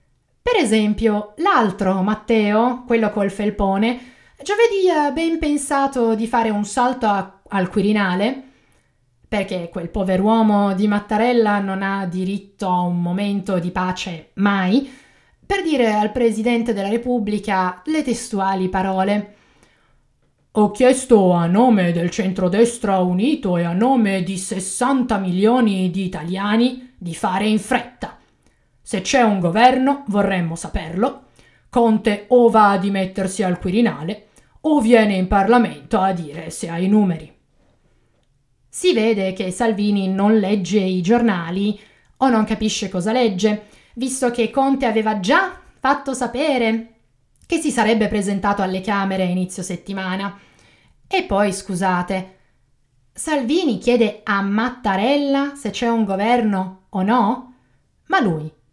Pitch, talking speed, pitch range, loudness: 210 Hz, 130 wpm, 190-245 Hz, -19 LUFS